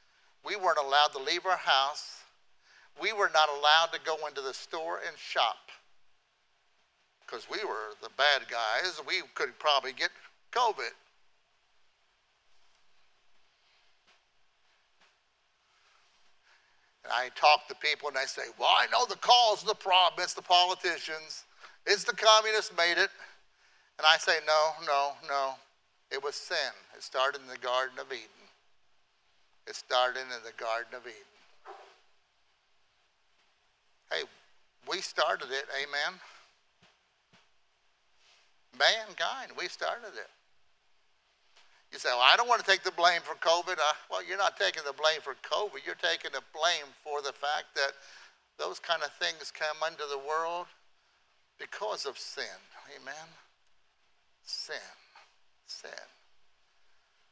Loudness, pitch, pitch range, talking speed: -29 LUFS, 160 Hz, 145-180 Hz, 135 wpm